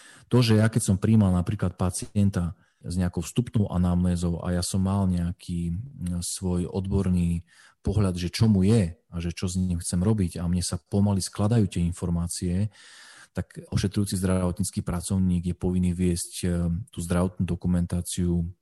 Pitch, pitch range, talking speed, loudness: 90 Hz, 90-100 Hz, 155 wpm, -26 LUFS